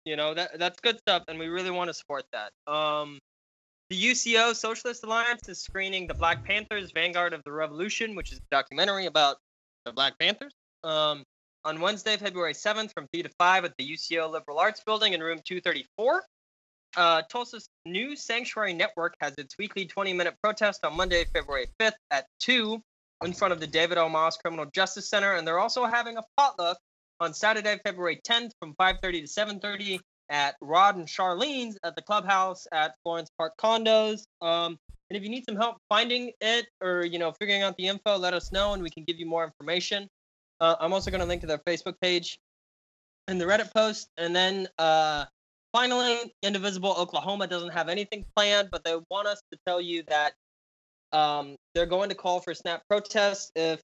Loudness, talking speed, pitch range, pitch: -27 LUFS, 195 wpm, 165-210 Hz, 185 Hz